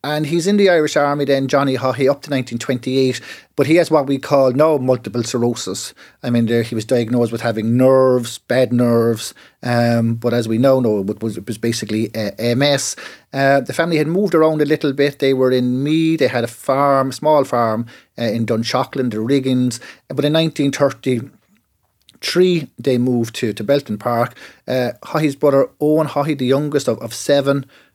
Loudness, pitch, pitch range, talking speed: -17 LUFS, 130 Hz, 120-145 Hz, 190 wpm